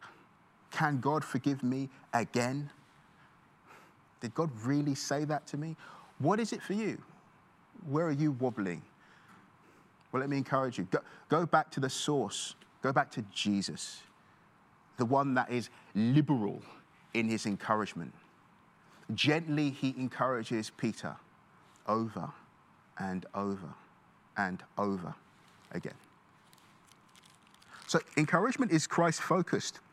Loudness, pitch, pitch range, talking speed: -33 LUFS, 135 Hz, 115-155 Hz, 120 wpm